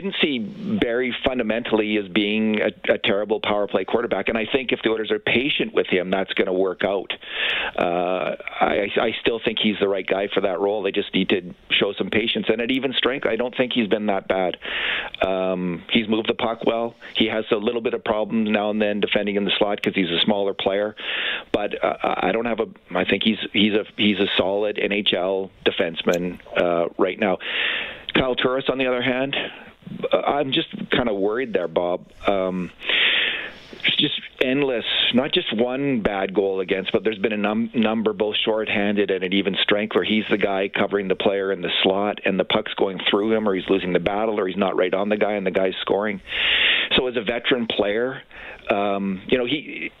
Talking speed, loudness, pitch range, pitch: 210 wpm, -22 LUFS, 100-115 Hz, 105 Hz